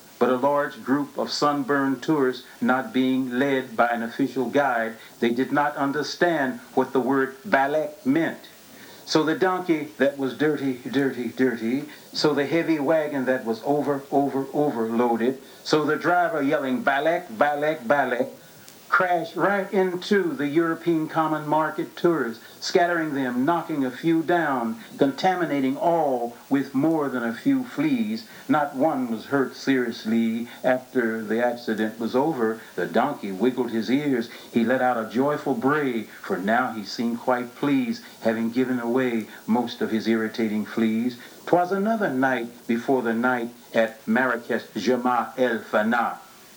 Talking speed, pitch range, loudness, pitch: 150 wpm, 120-155 Hz, -24 LUFS, 135 Hz